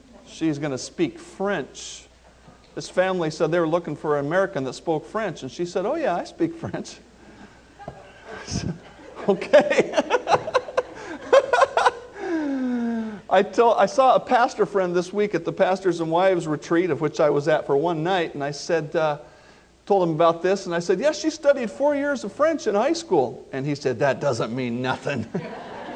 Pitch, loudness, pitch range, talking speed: 190 Hz, -23 LUFS, 155-245 Hz, 185 wpm